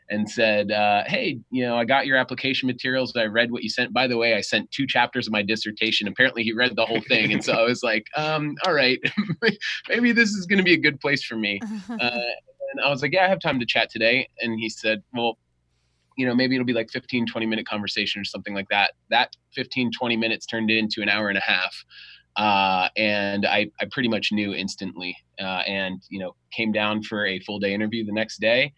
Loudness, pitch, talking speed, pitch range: -23 LUFS, 115 Hz, 240 wpm, 105-130 Hz